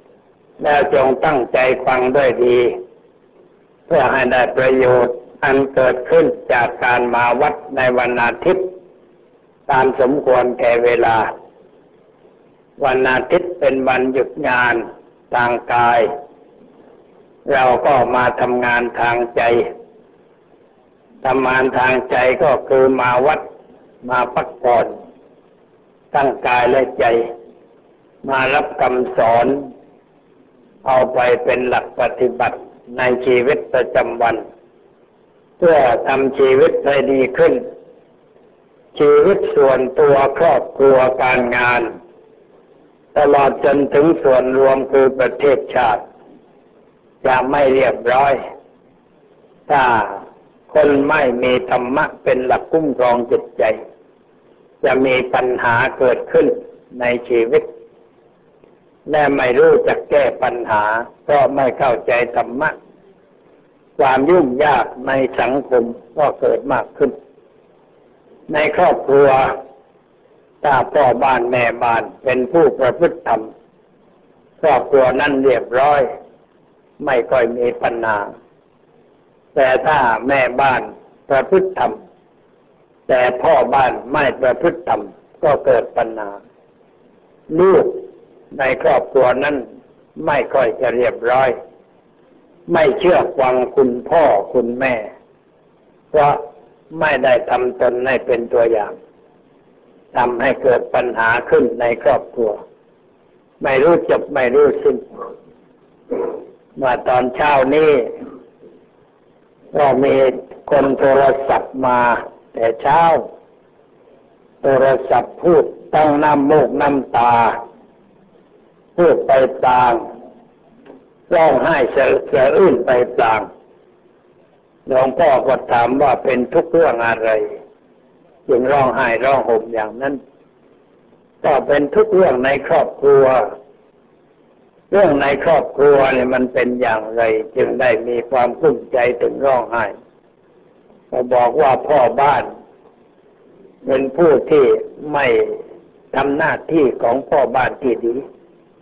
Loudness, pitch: -15 LUFS, 135 Hz